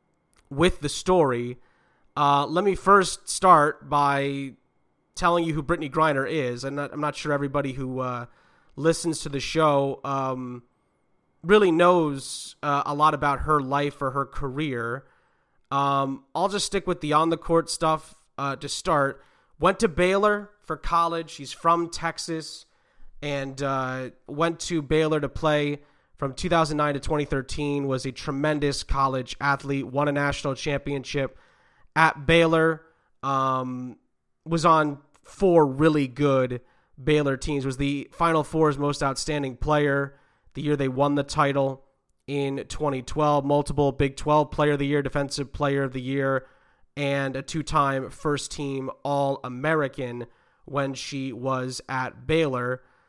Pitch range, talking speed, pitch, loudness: 135-155 Hz, 145 wpm, 145 Hz, -24 LUFS